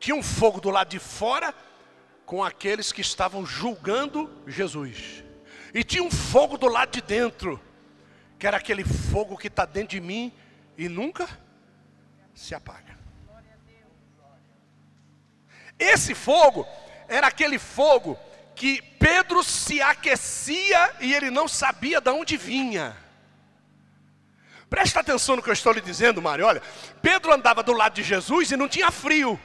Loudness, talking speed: -22 LUFS, 145 wpm